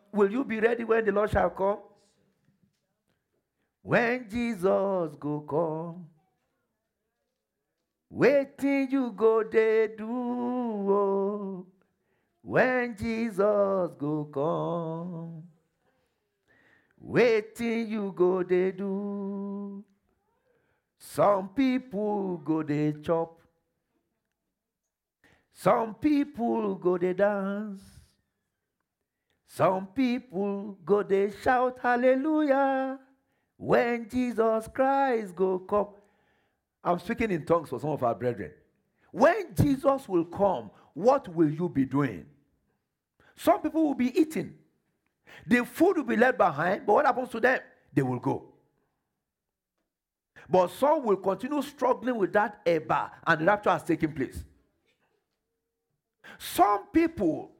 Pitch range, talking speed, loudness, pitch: 175-250 Hz, 105 wpm, -27 LUFS, 205 Hz